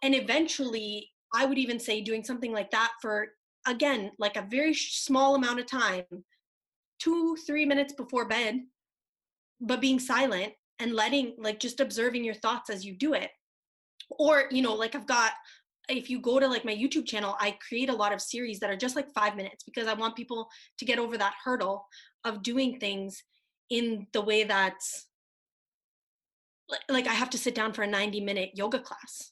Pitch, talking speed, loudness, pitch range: 240 Hz, 190 wpm, -29 LUFS, 215-265 Hz